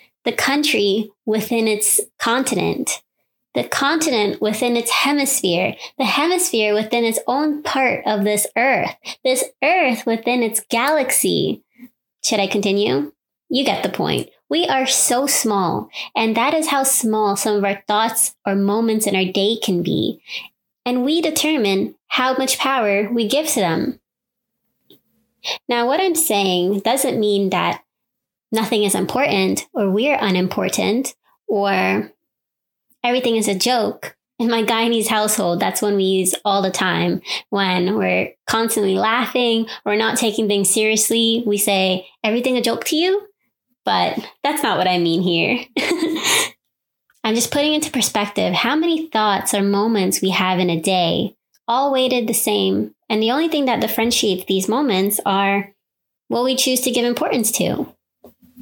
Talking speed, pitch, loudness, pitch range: 150 wpm, 225 Hz, -18 LUFS, 200-260 Hz